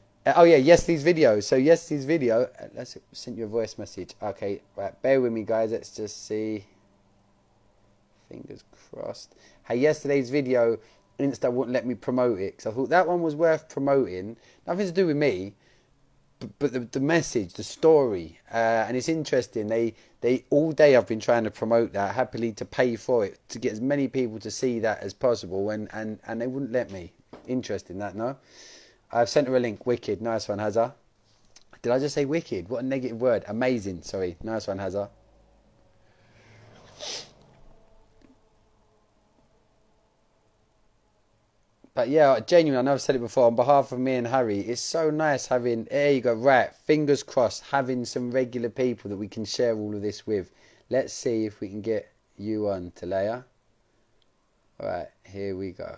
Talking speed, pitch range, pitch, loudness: 180 wpm, 105-135 Hz, 115 Hz, -25 LUFS